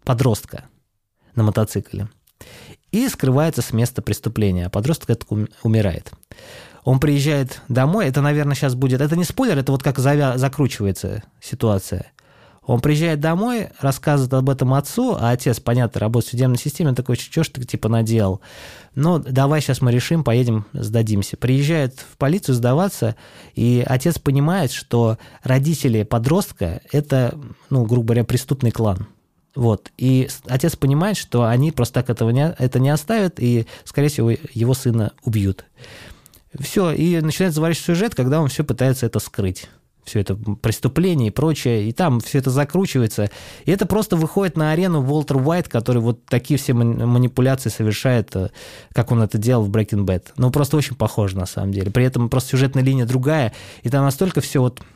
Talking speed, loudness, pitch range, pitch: 165 wpm, -19 LUFS, 115-145 Hz, 130 Hz